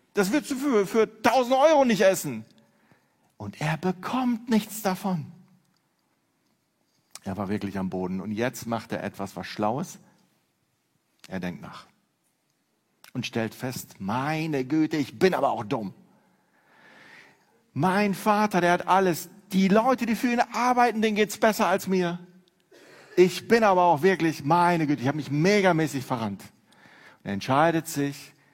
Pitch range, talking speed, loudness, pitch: 140-205 Hz, 145 wpm, -25 LUFS, 180 Hz